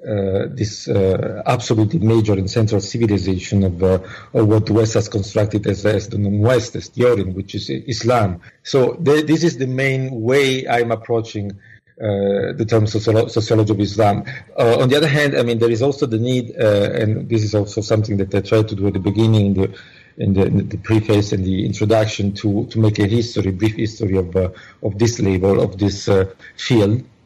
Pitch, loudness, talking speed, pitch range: 110 Hz, -18 LUFS, 205 wpm, 100-115 Hz